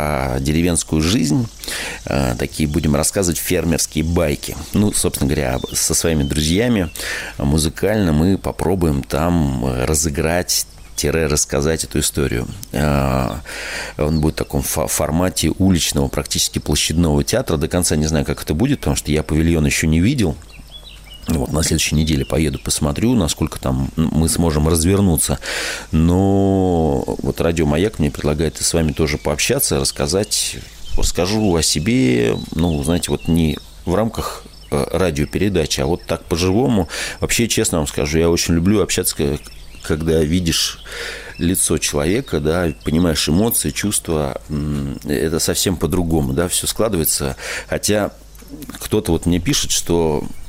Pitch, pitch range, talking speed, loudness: 80 Hz, 75-85 Hz, 130 wpm, -18 LUFS